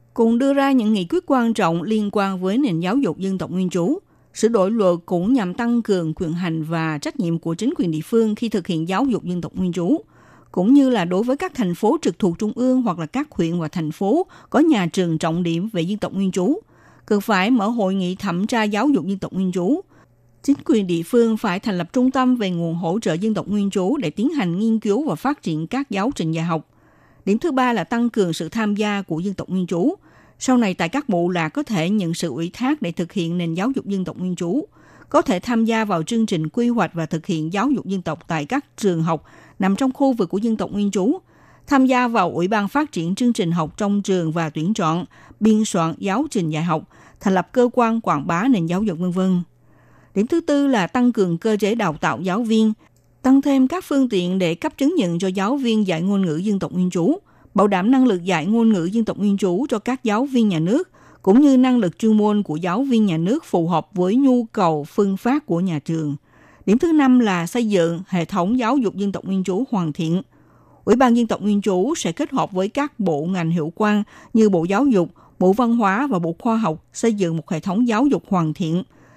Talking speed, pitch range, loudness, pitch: 250 wpm, 175-240 Hz, -20 LUFS, 200 Hz